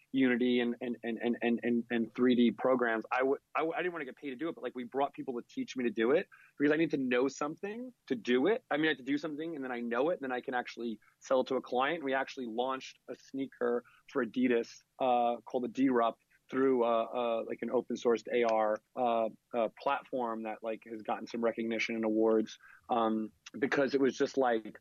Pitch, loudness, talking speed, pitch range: 125 Hz, -33 LUFS, 240 wpm, 115-135 Hz